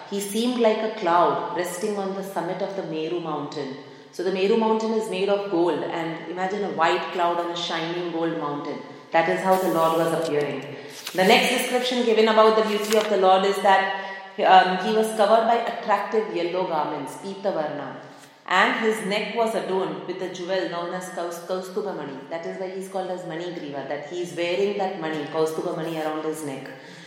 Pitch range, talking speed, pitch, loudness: 165-200 Hz, 195 wpm, 185 Hz, -23 LUFS